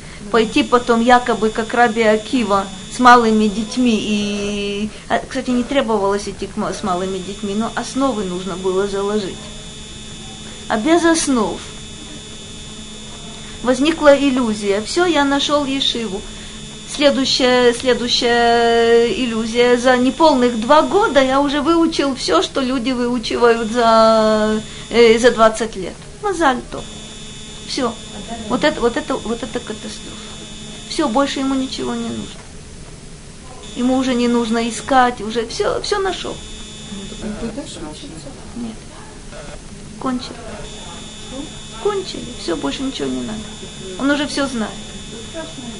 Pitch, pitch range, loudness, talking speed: 235 Hz, 210-265 Hz, -16 LUFS, 115 wpm